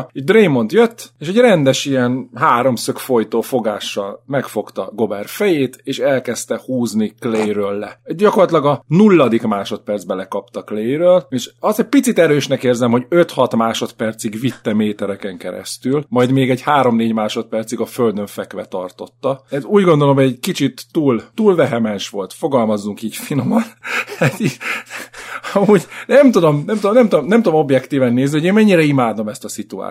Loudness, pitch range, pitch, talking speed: -16 LUFS, 115-175 Hz, 130 Hz, 155 wpm